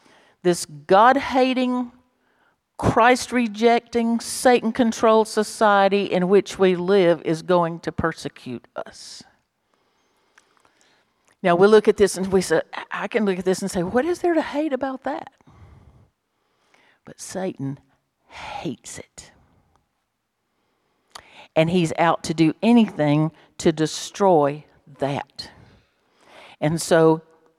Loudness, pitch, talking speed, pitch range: -20 LUFS, 195 Hz, 115 wpm, 165-235 Hz